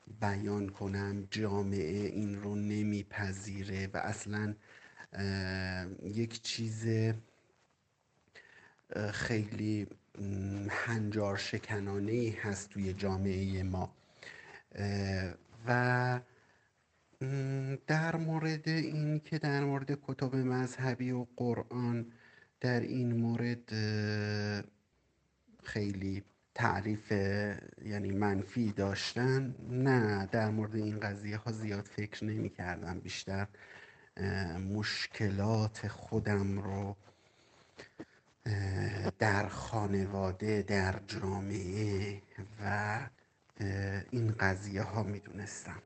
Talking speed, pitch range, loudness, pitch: 80 wpm, 100-115 Hz, -36 LUFS, 105 Hz